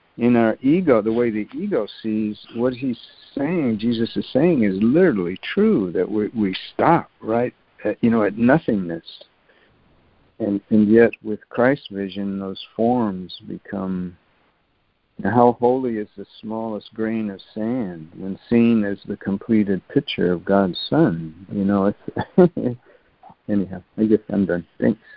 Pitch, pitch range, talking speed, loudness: 105 Hz, 100-115 Hz, 150 wpm, -21 LUFS